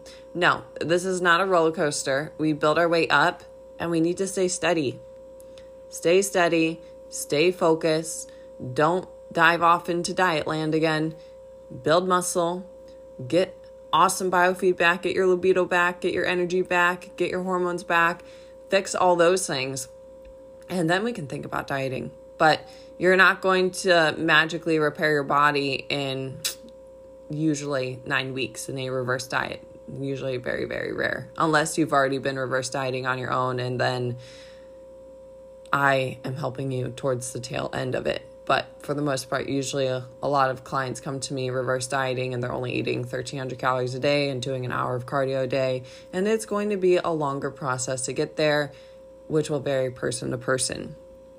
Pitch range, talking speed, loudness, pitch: 135-185 Hz, 175 wpm, -24 LUFS, 160 Hz